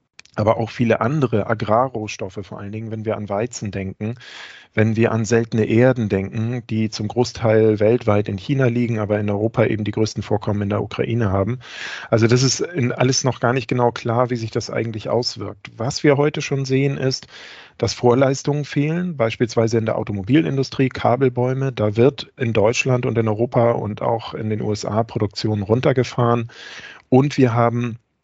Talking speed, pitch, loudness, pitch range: 175 wpm, 115 Hz, -20 LUFS, 110-125 Hz